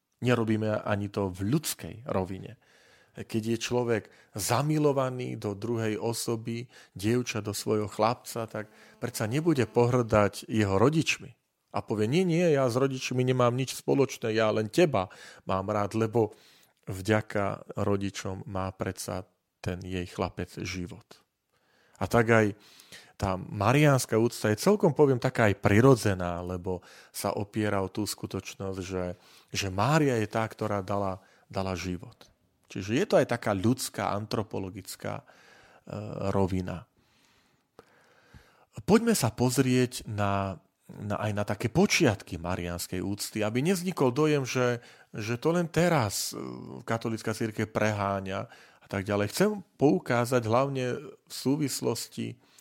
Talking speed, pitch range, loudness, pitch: 130 wpm, 100-125 Hz, -28 LUFS, 110 Hz